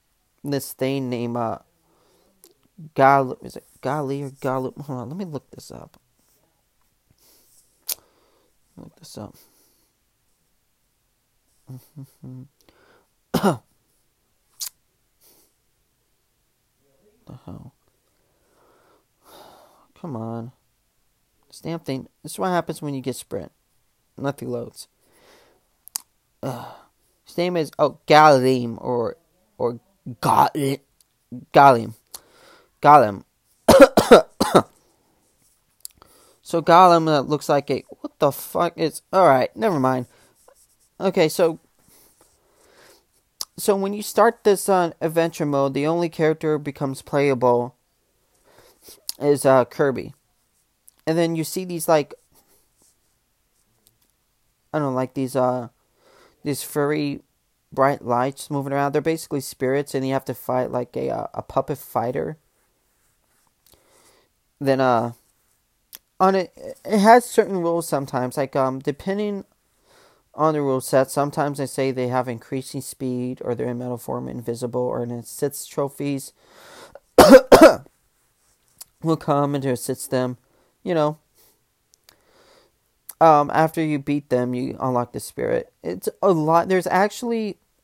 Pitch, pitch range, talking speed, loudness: 140 Hz, 130-170 Hz, 115 wpm, -20 LUFS